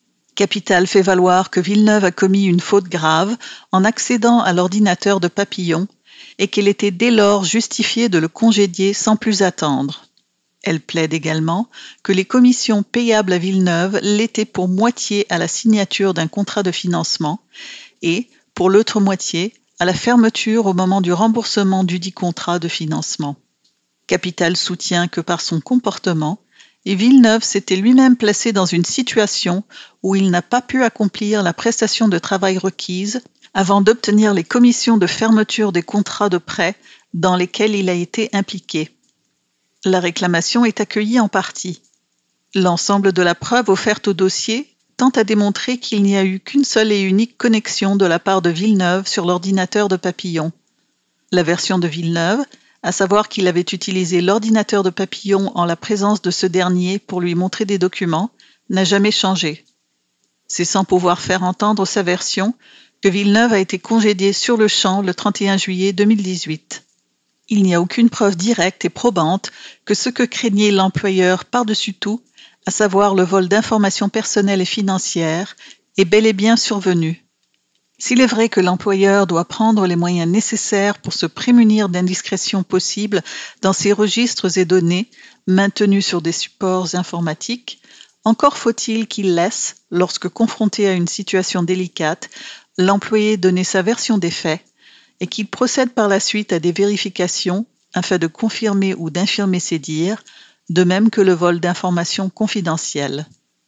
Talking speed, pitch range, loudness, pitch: 160 wpm, 180-215 Hz, -16 LUFS, 195 Hz